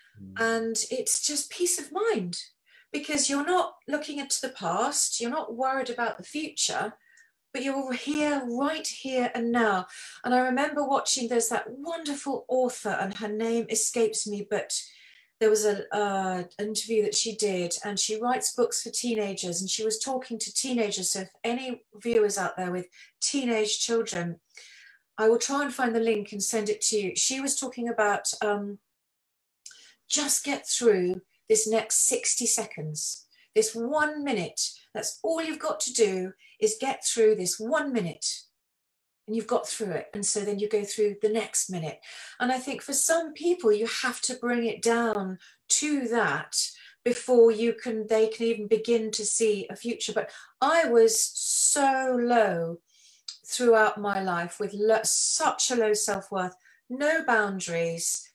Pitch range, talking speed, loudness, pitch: 210-275 Hz, 170 wpm, -27 LUFS, 230 Hz